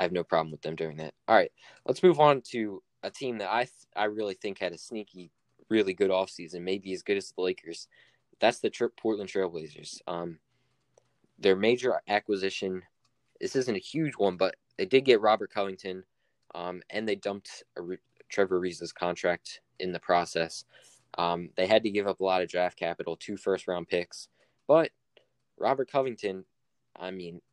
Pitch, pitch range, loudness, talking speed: 95 Hz, 90-105 Hz, -29 LUFS, 185 wpm